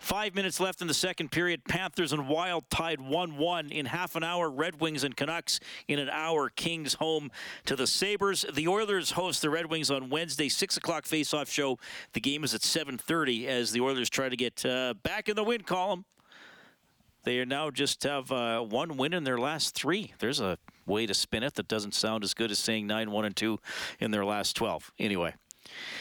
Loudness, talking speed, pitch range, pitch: -30 LUFS, 210 wpm, 125-175 Hz, 155 Hz